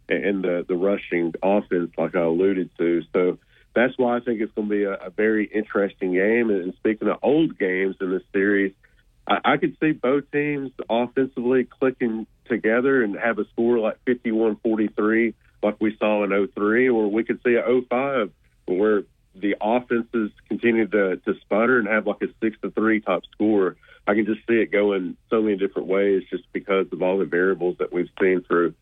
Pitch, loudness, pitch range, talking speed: 105 Hz, -22 LUFS, 100-115 Hz, 195 wpm